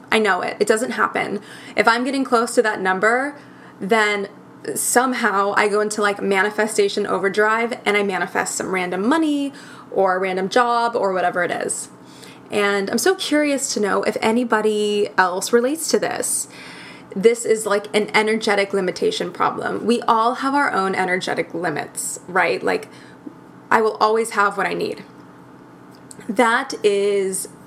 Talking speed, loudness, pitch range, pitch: 155 wpm, -19 LUFS, 200-240 Hz, 215 Hz